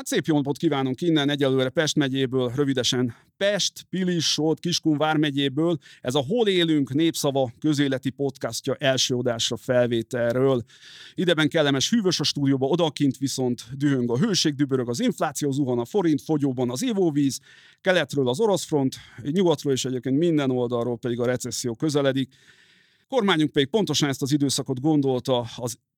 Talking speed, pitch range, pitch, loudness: 150 wpm, 130-155 Hz, 140 Hz, -23 LUFS